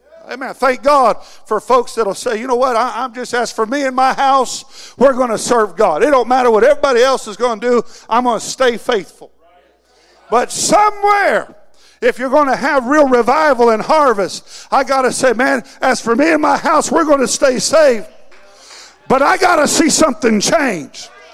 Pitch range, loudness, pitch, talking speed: 235-285 Hz, -13 LUFS, 260 Hz, 205 wpm